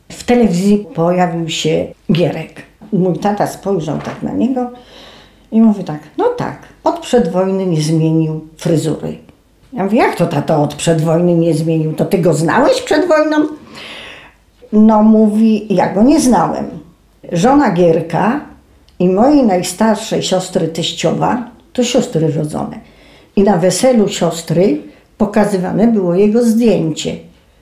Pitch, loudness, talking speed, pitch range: 185 Hz, -13 LUFS, 130 wpm, 165-225 Hz